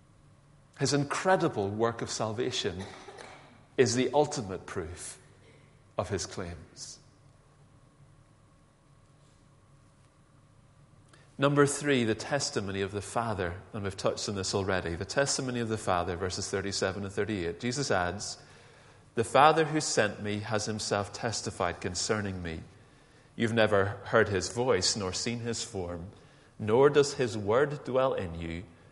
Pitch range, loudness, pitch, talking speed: 100-140 Hz, -30 LUFS, 115 Hz, 130 wpm